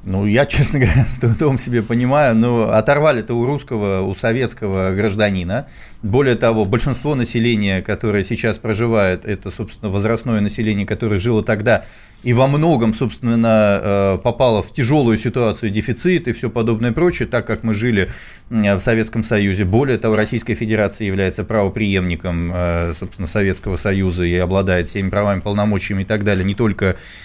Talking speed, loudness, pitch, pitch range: 155 wpm, -17 LUFS, 110 Hz, 100-120 Hz